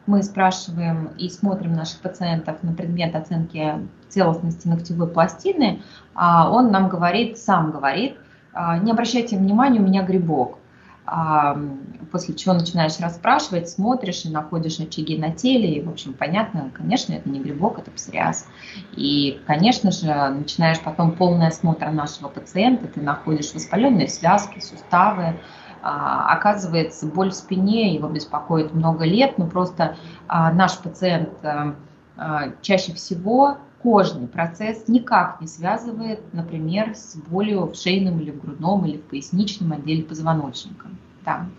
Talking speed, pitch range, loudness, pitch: 130 wpm, 160-195 Hz, -21 LUFS, 170 Hz